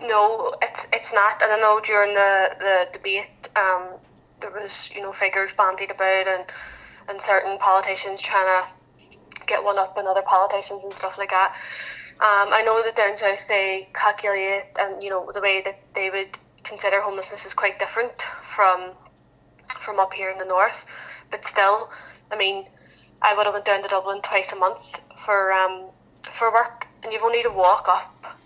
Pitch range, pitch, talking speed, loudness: 190-210 Hz, 200 Hz, 185 wpm, -21 LUFS